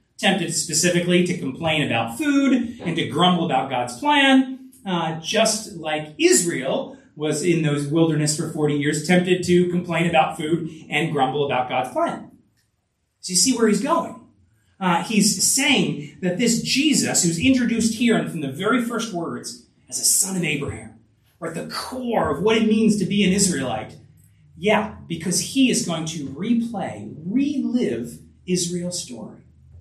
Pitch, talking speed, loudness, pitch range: 180 Hz, 160 wpm, -21 LUFS, 155-225 Hz